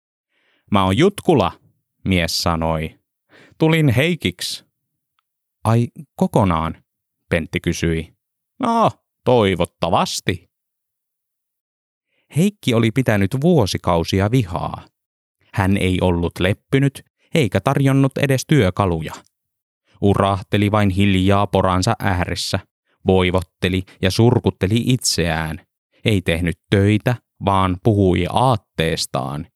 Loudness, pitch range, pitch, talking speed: -18 LUFS, 90-120 Hz, 100 Hz, 85 wpm